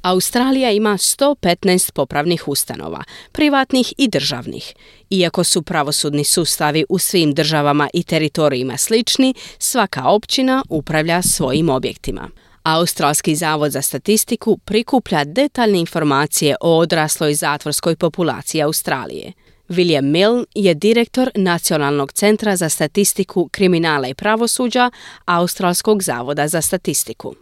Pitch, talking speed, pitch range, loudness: 175 Hz, 110 wpm, 150-210 Hz, -16 LUFS